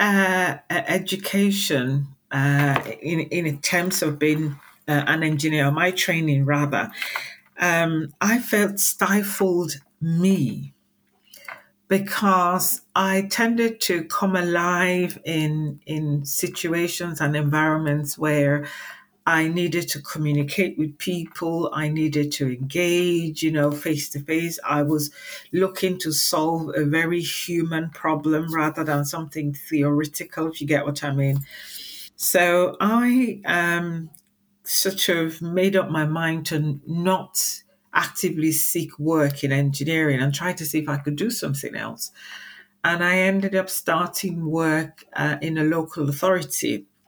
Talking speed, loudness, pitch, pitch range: 130 wpm, -22 LUFS, 160 Hz, 150-180 Hz